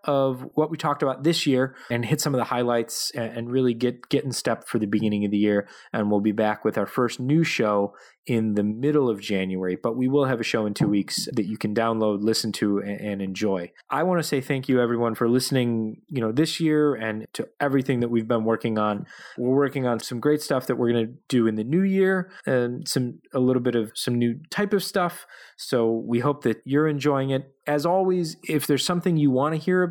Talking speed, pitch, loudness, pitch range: 240 wpm, 125 Hz, -24 LUFS, 110-145 Hz